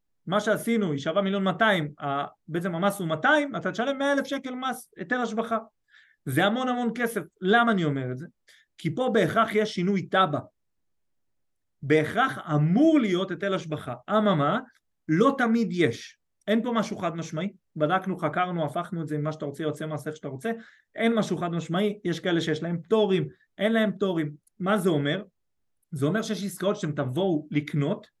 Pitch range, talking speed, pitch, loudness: 155-220 Hz, 175 wpm, 190 Hz, -26 LUFS